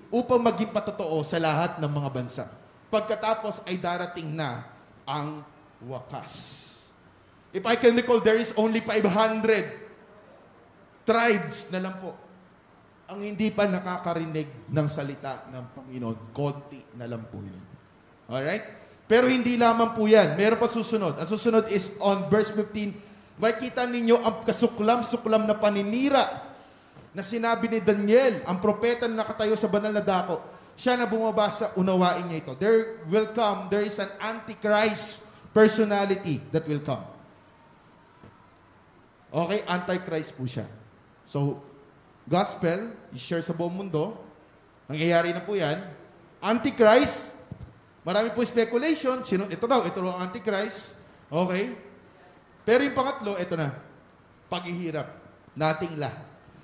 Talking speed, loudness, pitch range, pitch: 130 wpm, -26 LUFS, 155-220 Hz, 200 Hz